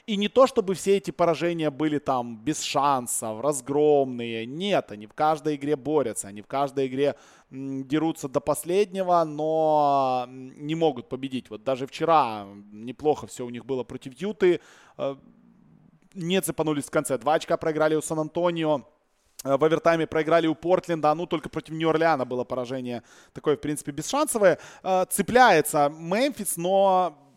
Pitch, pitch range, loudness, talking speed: 150 Hz, 135-170 Hz, -25 LUFS, 145 wpm